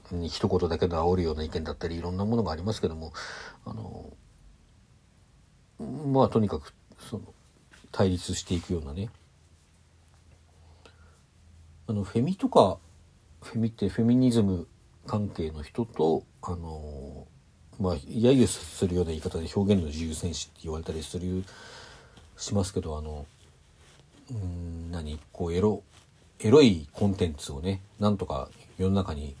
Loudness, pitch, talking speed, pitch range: -28 LUFS, 90 Hz, 280 characters per minute, 80-100 Hz